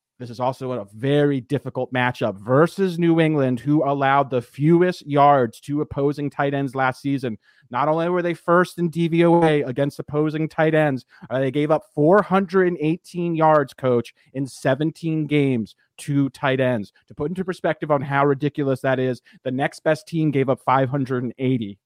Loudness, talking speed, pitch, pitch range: -21 LUFS, 165 wpm, 145 Hz, 130-160 Hz